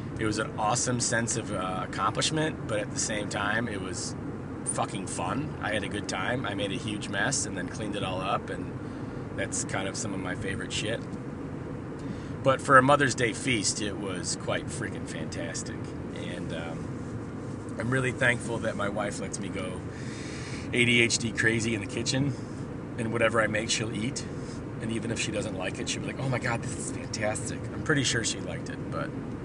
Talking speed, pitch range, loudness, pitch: 200 wpm, 110-130 Hz, -29 LUFS, 120 Hz